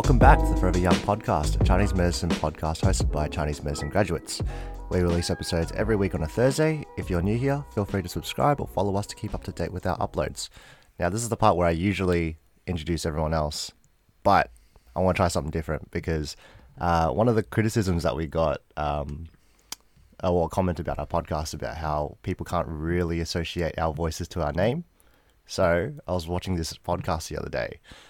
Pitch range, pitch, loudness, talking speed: 80-95 Hz, 85 Hz, -26 LUFS, 205 wpm